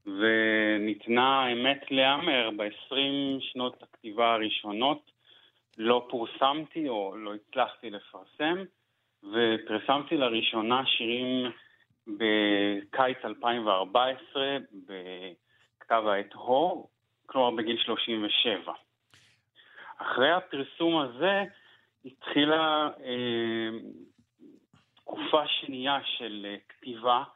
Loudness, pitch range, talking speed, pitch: -28 LUFS, 110-135 Hz, 75 wpm, 125 Hz